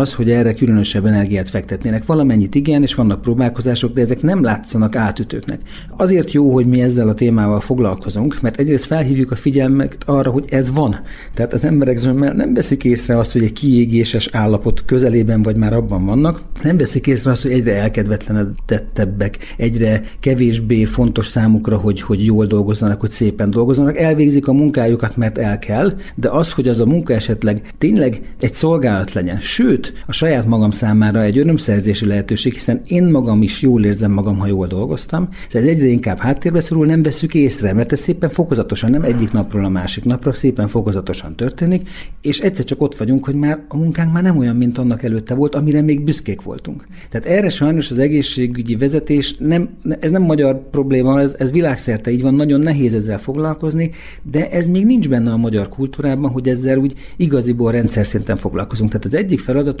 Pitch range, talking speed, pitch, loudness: 110-145 Hz, 185 wpm, 125 Hz, -15 LUFS